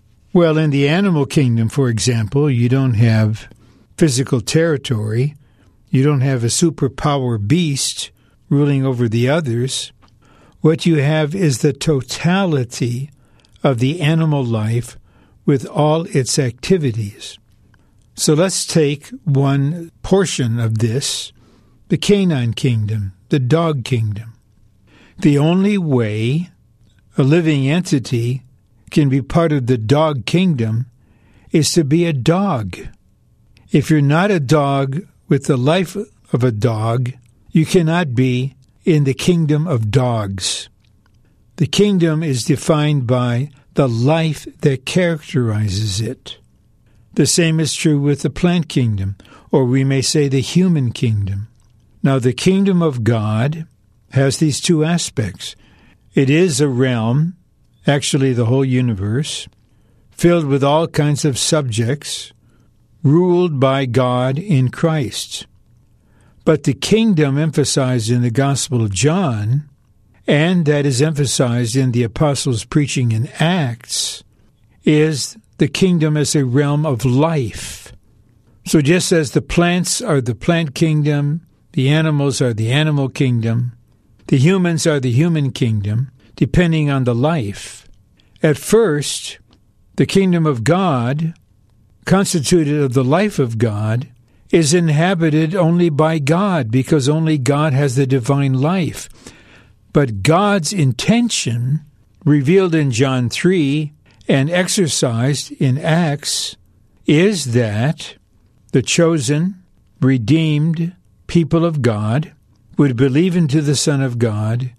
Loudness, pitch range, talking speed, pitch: -16 LUFS, 120-160 Hz, 125 wpm, 140 Hz